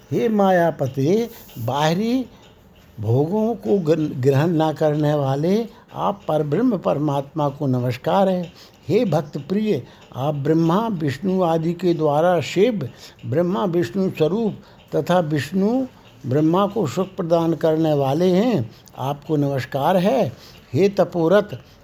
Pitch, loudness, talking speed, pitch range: 165 Hz, -20 LUFS, 120 wpm, 145-195 Hz